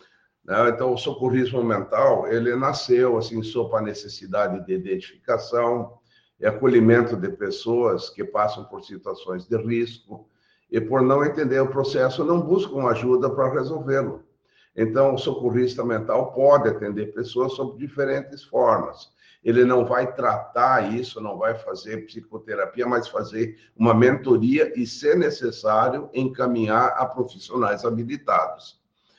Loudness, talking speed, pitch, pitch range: -22 LUFS, 130 wpm, 125 Hz, 115-135 Hz